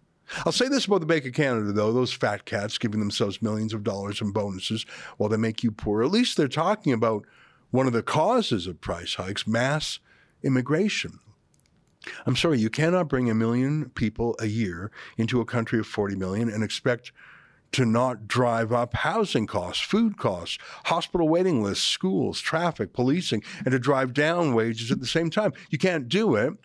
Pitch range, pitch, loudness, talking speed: 110-155 Hz, 120 Hz, -25 LUFS, 185 wpm